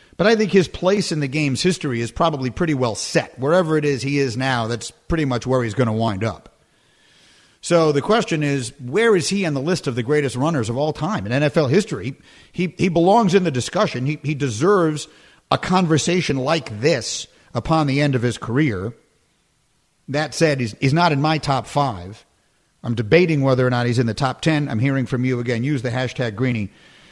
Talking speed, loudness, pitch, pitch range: 210 wpm, -20 LUFS, 140 Hz, 125-165 Hz